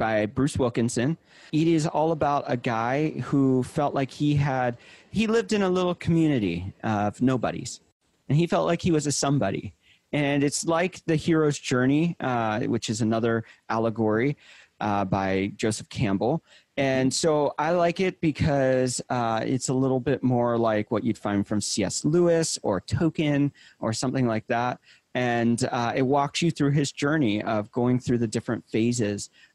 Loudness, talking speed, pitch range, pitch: -25 LUFS, 170 wpm, 115-150 Hz, 130 Hz